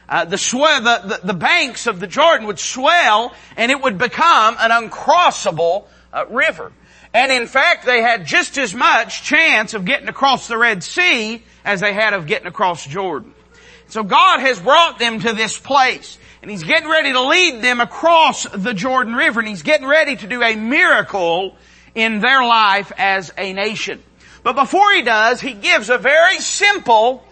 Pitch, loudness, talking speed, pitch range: 245 Hz, -14 LUFS, 185 wpm, 220-305 Hz